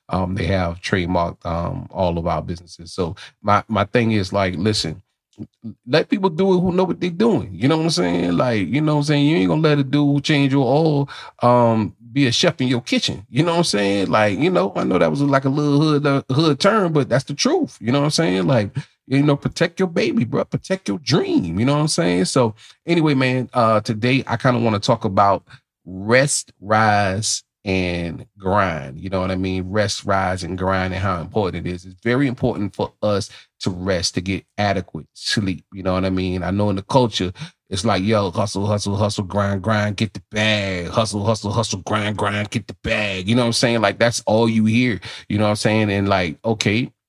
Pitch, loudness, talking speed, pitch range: 110 Hz, -19 LUFS, 230 wpm, 95-135 Hz